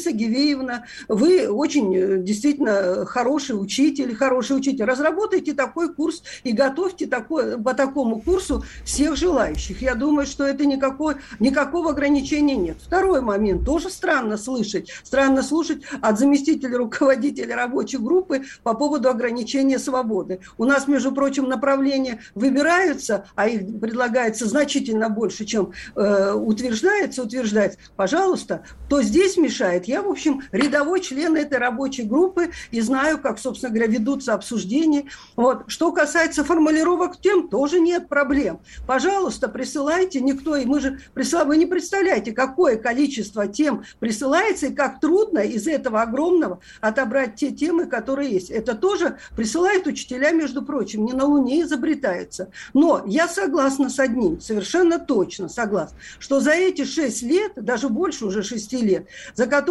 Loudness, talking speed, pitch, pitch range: -21 LUFS, 140 wpm, 270 Hz, 235-310 Hz